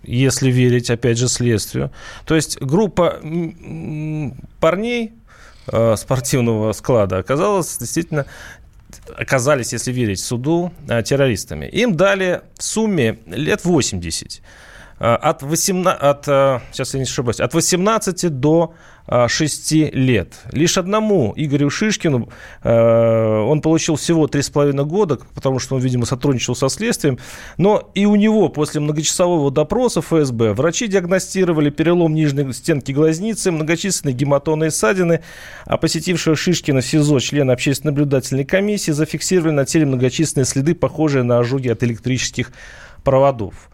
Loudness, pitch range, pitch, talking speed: -17 LUFS, 130-170 Hz, 150 Hz, 125 wpm